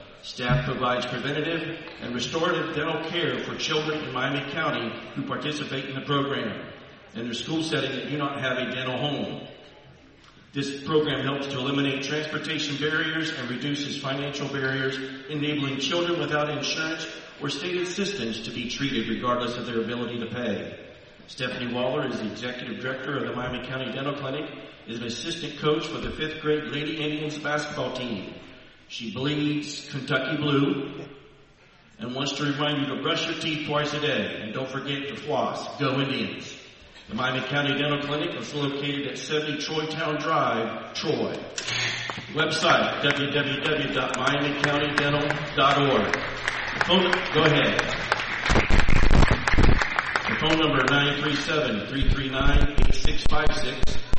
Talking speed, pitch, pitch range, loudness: 140 wpm, 140 Hz, 130-150 Hz, -26 LUFS